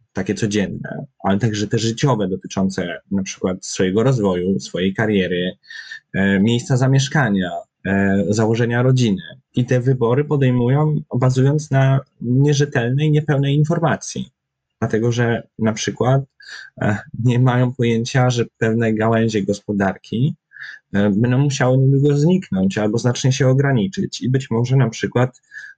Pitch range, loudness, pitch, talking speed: 105-135 Hz, -18 LUFS, 120 Hz, 115 wpm